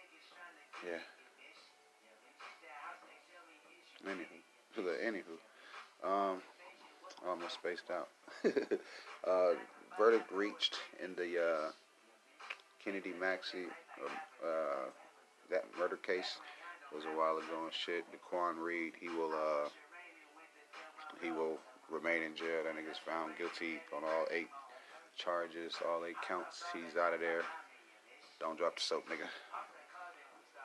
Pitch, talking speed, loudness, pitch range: 85 Hz, 115 wpm, -40 LUFS, 80-85 Hz